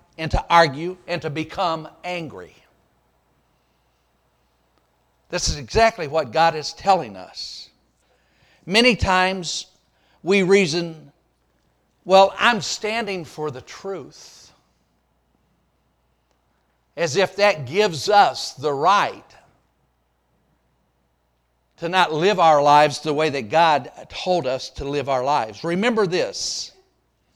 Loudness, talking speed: -20 LUFS, 105 wpm